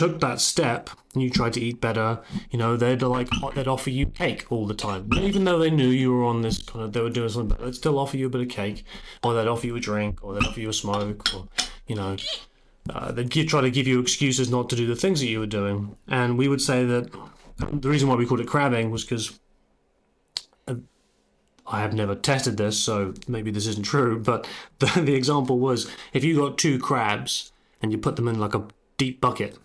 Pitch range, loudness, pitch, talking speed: 110-130 Hz, -24 LUFS, 120 Hz, 235 wpm